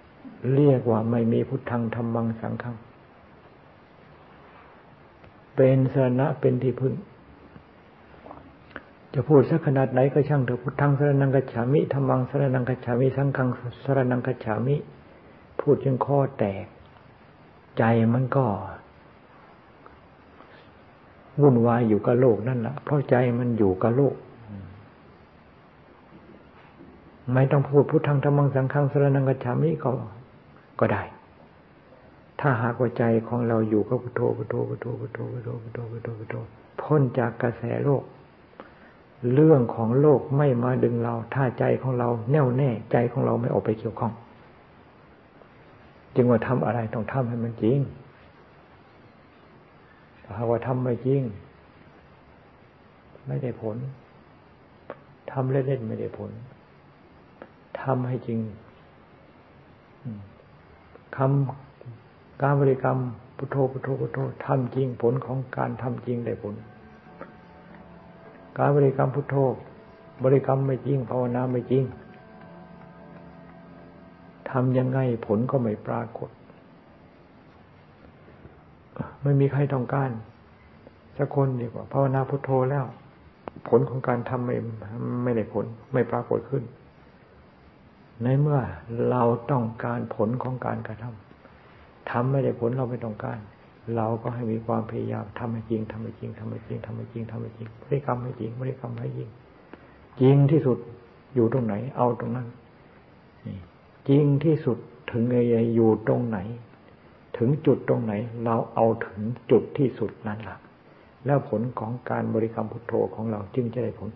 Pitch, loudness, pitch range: 120 Hz, -25 LUFS, 115-135 Hz